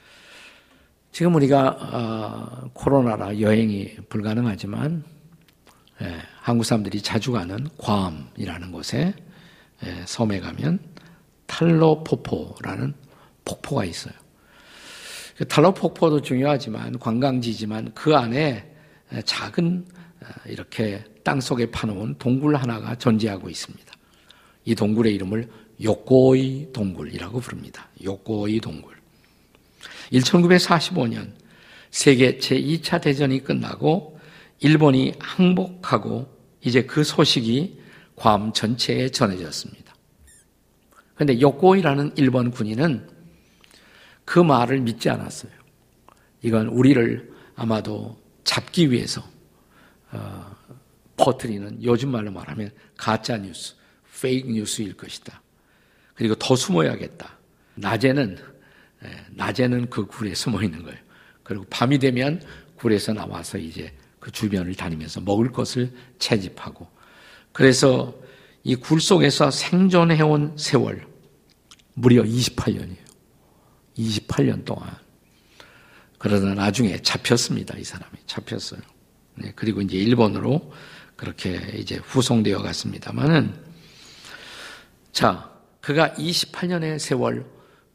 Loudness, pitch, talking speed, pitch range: -22 LUFS, 120 Hz, 230 characters per minute, 110-145 Hz